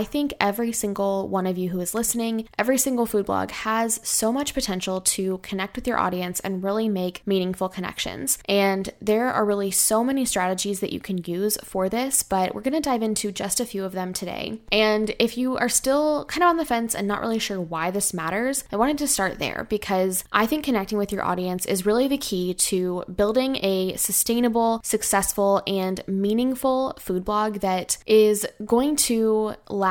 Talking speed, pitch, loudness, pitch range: 200 wpm, 210 Hz, -23 LUFS, 190-235 Hz